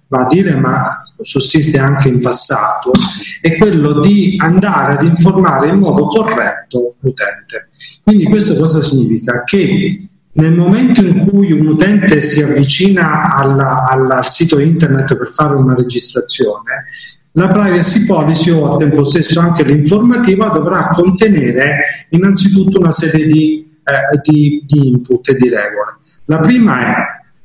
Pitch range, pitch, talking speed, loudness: 140-190 Hz, 160 Hz, 140 wpm, -10 LUFS